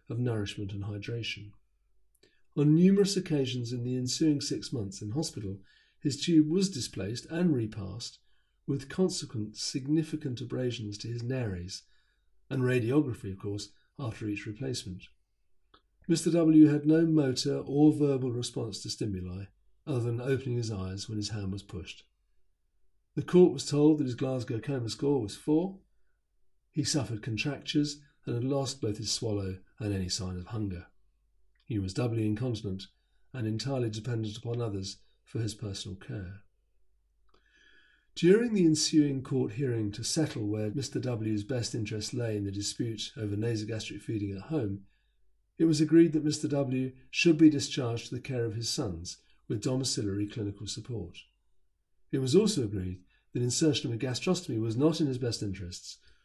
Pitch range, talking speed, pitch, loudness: 105-145 Hz, 155 wpm, 120 Hz, -30 LUFS